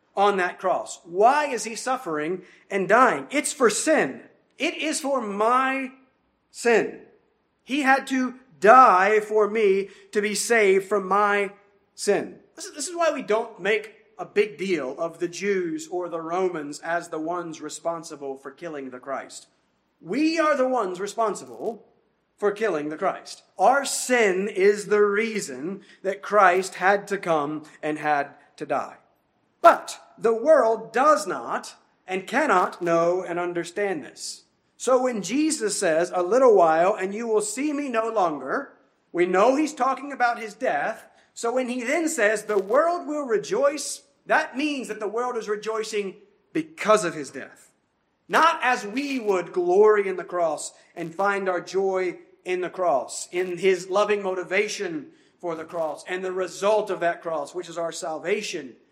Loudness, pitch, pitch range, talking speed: -23 LUFS, 205 Hz, 180-260 Hz, 160 wpm